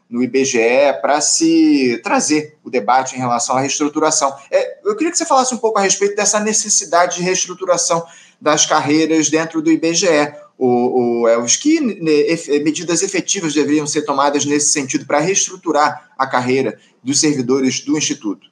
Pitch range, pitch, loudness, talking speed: 140-195 Hz, 155 Hz, -15 LUFS, 155 wpm